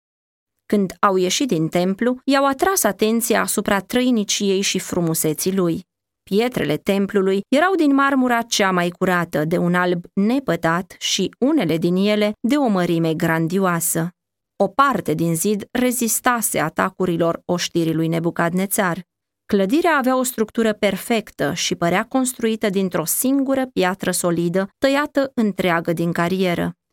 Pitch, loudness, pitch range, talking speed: 195 Hz, -19 LUFS, 175-235 Hz, 130 wpm